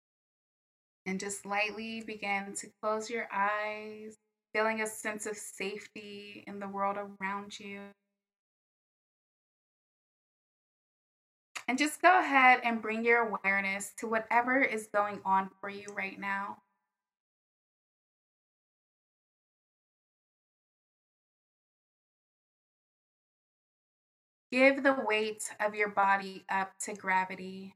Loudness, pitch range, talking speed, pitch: -31 LUFS, 200-220 Hz, 95 wpm, 210 Hz